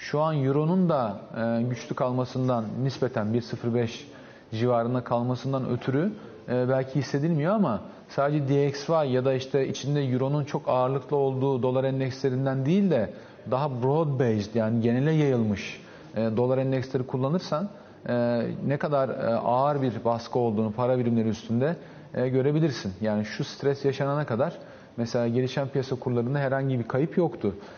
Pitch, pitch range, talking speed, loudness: 130 Hz, 120-140 Hz, 130 wpm, -27 LUFS